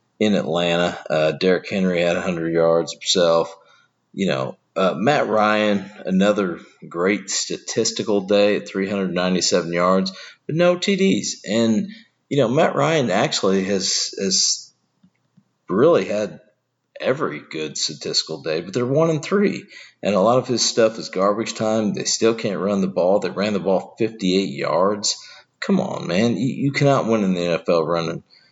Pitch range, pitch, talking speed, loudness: 90-115 Hz, 100 Hz, 160 wpm, -20 LUFS